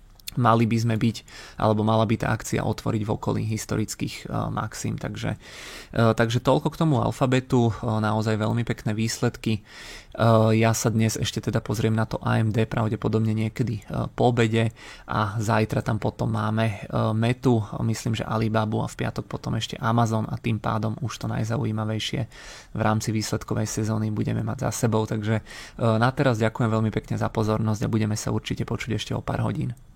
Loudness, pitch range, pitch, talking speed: -25 LUFS, 110-120 Hz, 110 Hz, 180 wpm